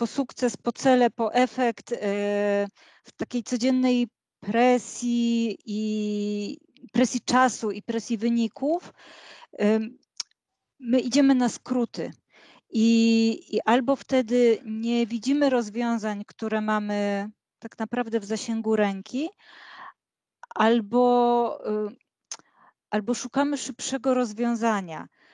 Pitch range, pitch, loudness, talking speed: 215-250 Hz, 235 Hz, -25 LUFS, 90 wpm